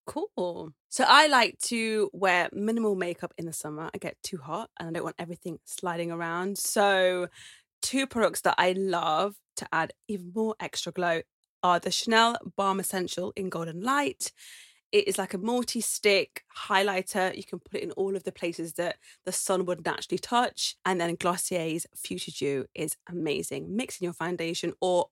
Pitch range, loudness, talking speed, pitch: 170-200 Hz, -28 LUFS, 180 wpm, 185 Hz